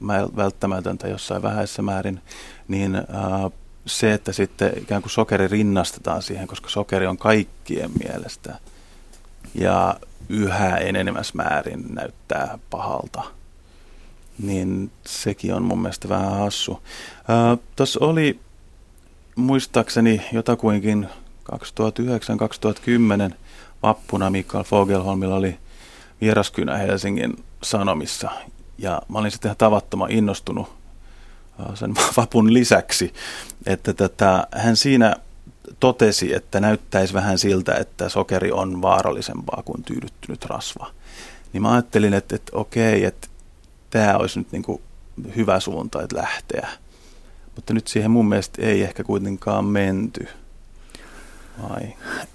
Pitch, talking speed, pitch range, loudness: 100 Hz, 110 wpm, 95-110 Hz, -21 LUFS